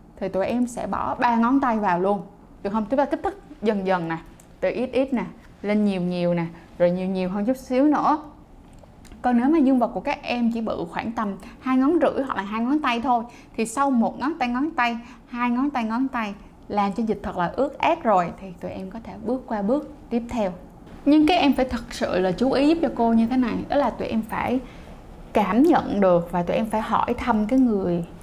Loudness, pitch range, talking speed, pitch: -23 LUFS, 205-260 Hz, 245 wpm, 235 Hz